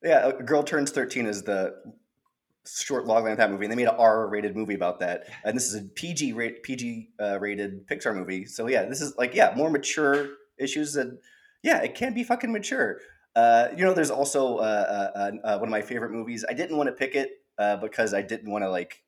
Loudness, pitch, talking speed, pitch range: -26 LUFS, 120 Hz, 230 wpm, 105-150 Hz